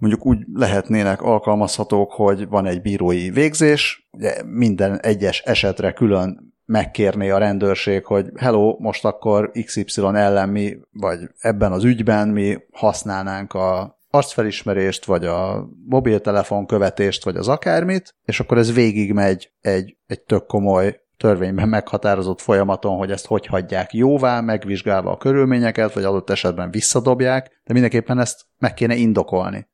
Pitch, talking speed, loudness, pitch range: 105 Hz, 135 wpm, -19 LUFS, 95-115 Hz